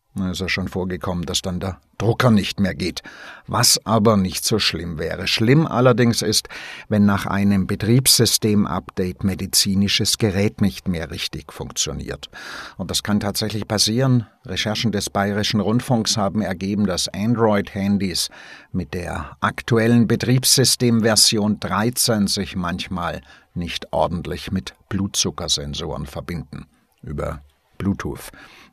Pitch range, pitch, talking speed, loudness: 95-115 Hz, 100 Hz, 120 wpm, -19 LUFS